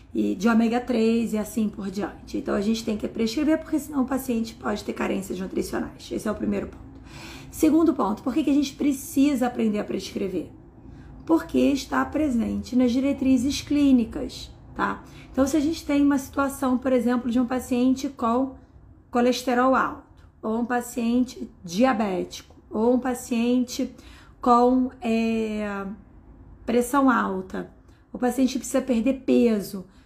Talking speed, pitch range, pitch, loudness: 150 wpm, 225-270 Hz, 250 Hz, -24 LUFS